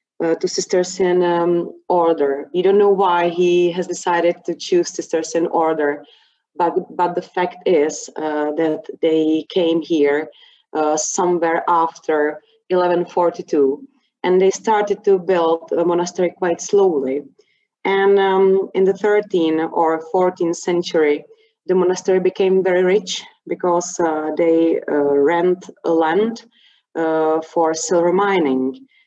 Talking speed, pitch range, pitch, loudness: 135 wpm, 165-190 Hz, 175 Hz, -18 LUFS